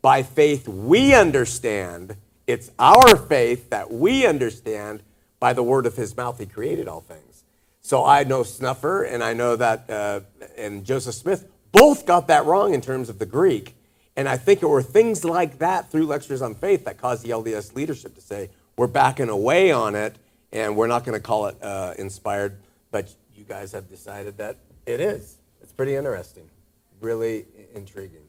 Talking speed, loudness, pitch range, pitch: 185 wpm, -20 LUFS, 105-135 Hz, 115 Hz